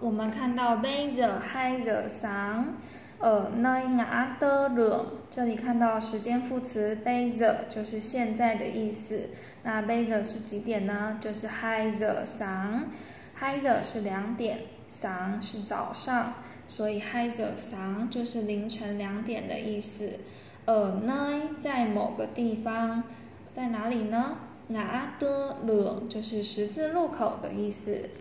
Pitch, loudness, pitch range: 225 Hz, -30 LUFS, 215-245 Hz